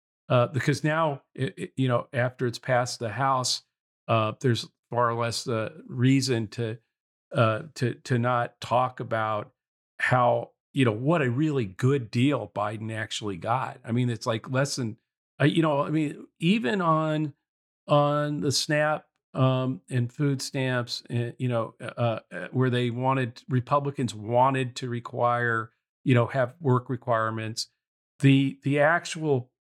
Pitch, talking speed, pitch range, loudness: 125 Hz, 155 wpm, 120-140 Hz, -26 LUFS